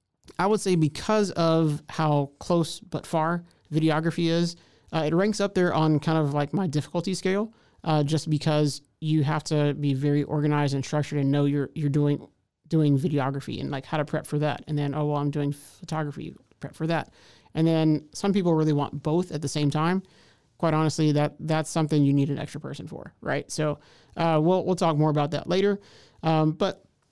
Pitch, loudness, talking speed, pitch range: 155 Hz, -26 LUFS, 205 wpm, 145-165 Hz